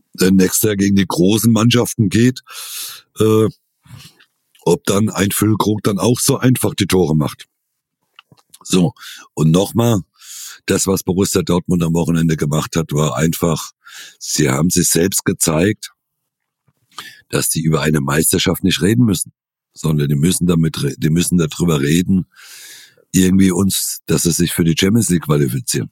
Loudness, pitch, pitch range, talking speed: -15 LUFS, 95 Hz, 80-105 Hz, 145 wpm